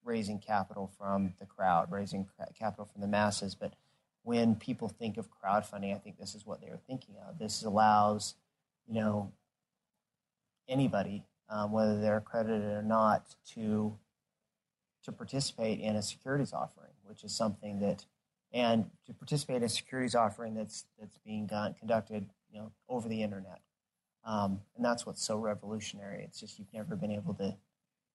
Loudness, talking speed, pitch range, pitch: -35 LUFS, 165 wpm, 105-110 Hz, 105 Hz